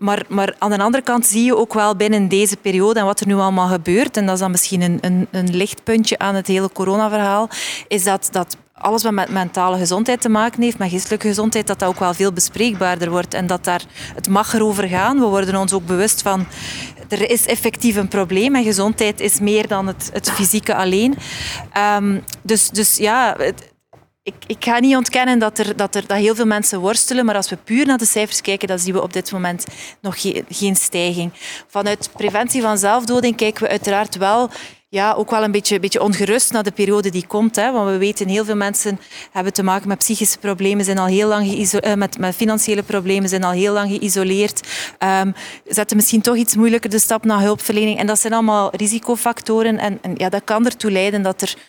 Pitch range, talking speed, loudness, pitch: 195-220 Hz, 220 wpm, -17 LUFS, 205 Hz